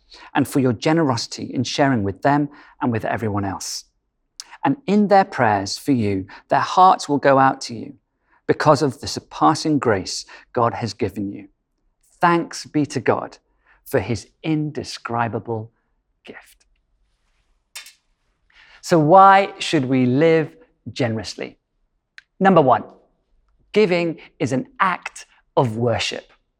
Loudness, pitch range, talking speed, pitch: -19 LUFS, 115-160 Hz, 125 wpm, 135 Hz